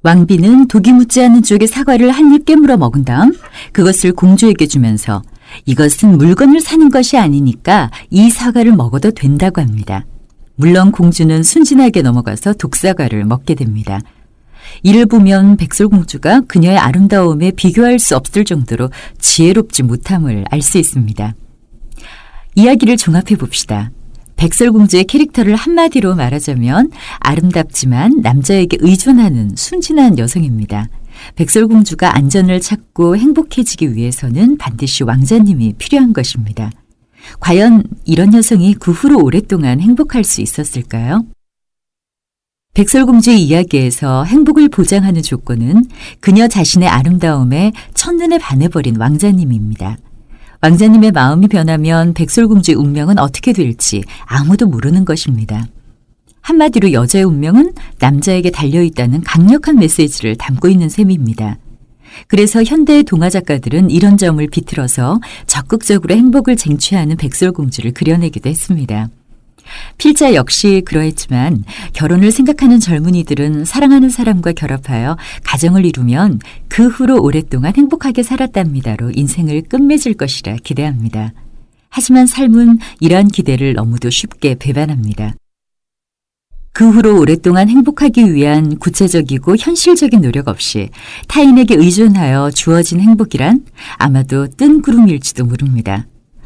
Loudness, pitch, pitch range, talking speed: -10 LUFS, 175 Hz, 135-220 Hz, 325 characters per minute